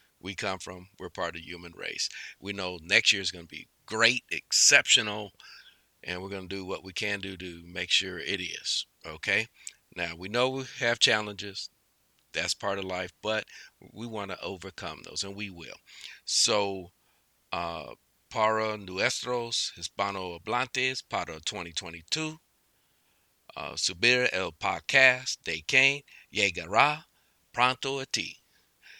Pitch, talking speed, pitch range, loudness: 100 Hz, 145 wpm, 90-125 Hz, -28 LUFS